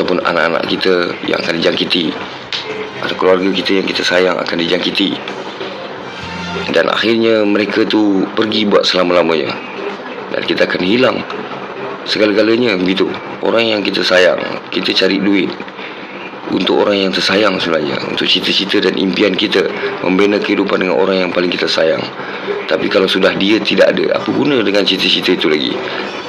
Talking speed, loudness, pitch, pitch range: 145 wpm, -14 LUFS, 100 Hz, 95-105 Hz